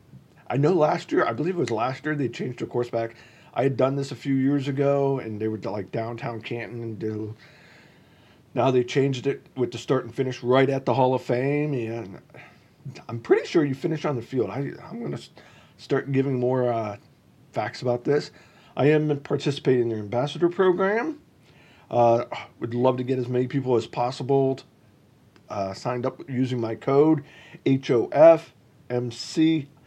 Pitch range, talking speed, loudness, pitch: 120-145 Hz, 190 wpm, -24 LUFS, 130 Hz